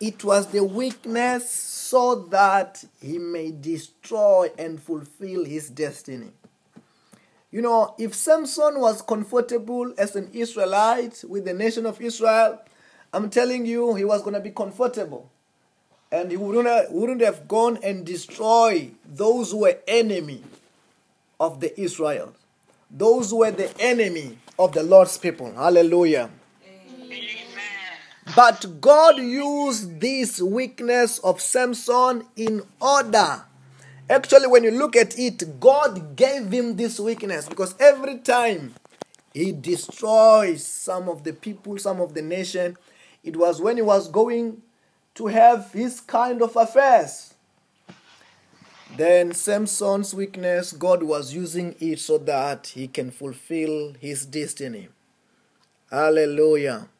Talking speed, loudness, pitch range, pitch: 125 wpm, -21 LUFS, 175-235 Hz, 205 Hz